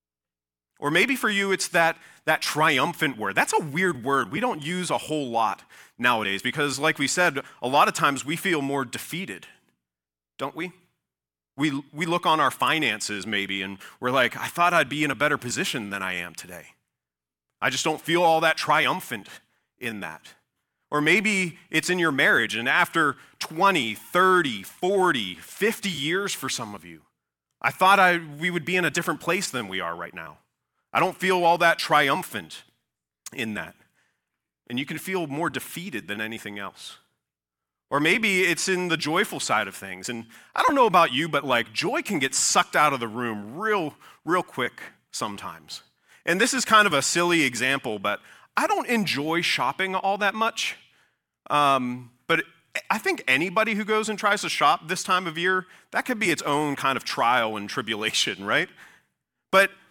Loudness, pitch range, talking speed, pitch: -23 LUFS, 115-185 Hz, 185 wpm, 155 Hz